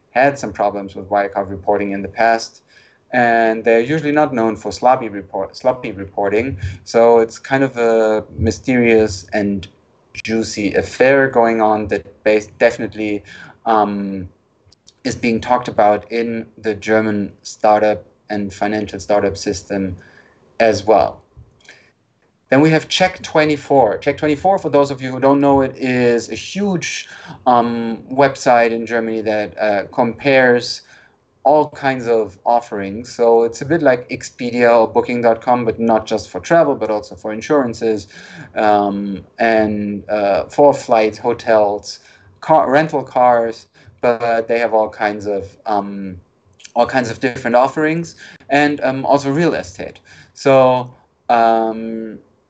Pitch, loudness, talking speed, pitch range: 115 Hz, -15 LUFS, 140 wpm, 105-130 Hz